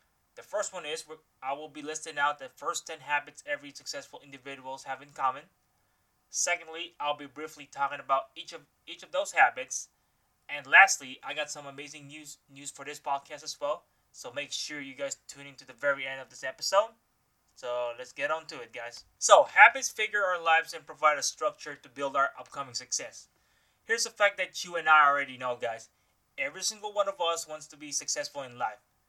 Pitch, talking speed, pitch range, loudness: 150 Hz, 205 wpm, 140-170 Hz, -28 LUFS